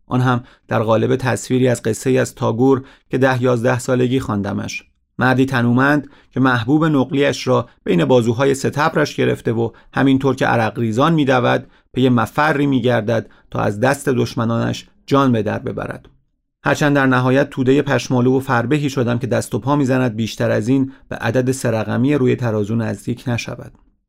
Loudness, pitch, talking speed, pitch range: -17 LUFS, 130 Hz, 165 wpm, 115-135 Hz